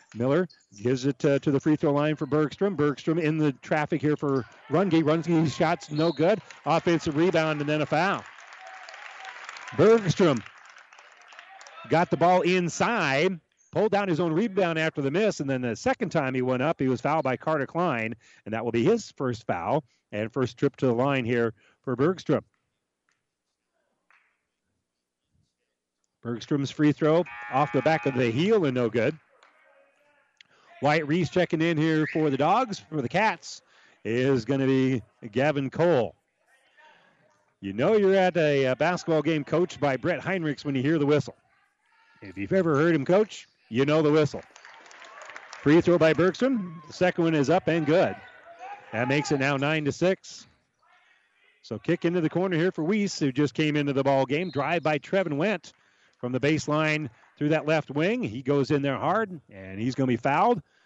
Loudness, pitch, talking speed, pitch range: -25 LUFS, 155 Hz, 180 wpm, 135-170 Hz